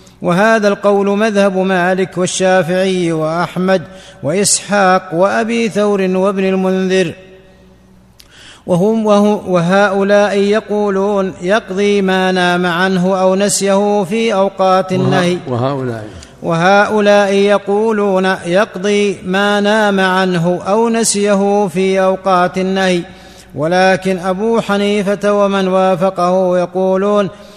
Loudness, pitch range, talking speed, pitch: -13 LUFS, 185-205 Hz, 90 wpm, 190 Hz